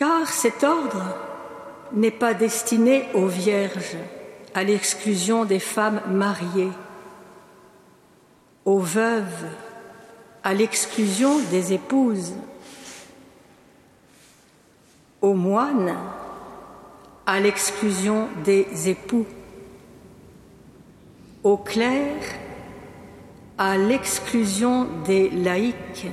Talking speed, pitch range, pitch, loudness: 70 wpm, 190-230 Hz, 205 Hz, -22 LUFS